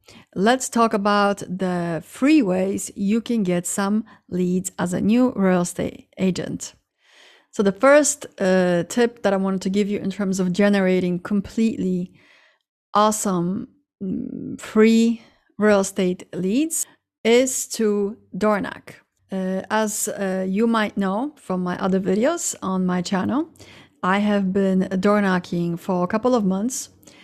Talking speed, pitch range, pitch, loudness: 145 wpm, 185-225 Hz, 200 Hz, -21 LUFS